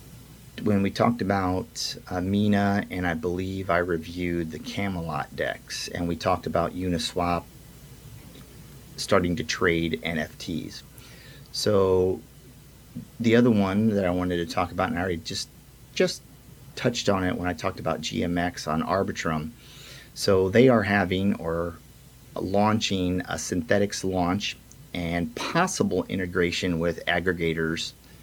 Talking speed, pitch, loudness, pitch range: 130 wpm, 95 Hz, -26 LUFS, 85-115 Hz